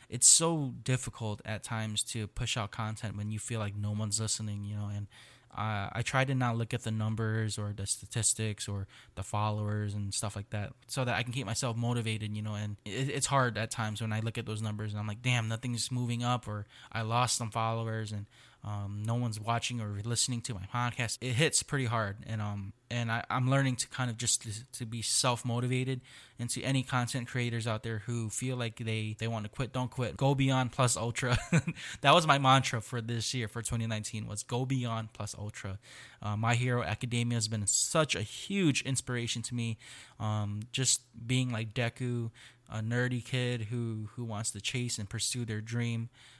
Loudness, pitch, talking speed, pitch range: -32 LUFS, 115 Hz, 210 wpm, 110-125 Hz